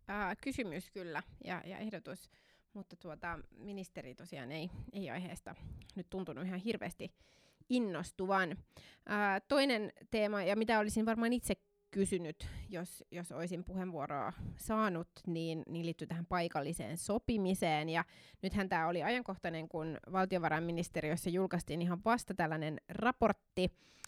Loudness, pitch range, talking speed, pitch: -38 LUFS, 165-205 Hz, 125 wpm, 185 Hz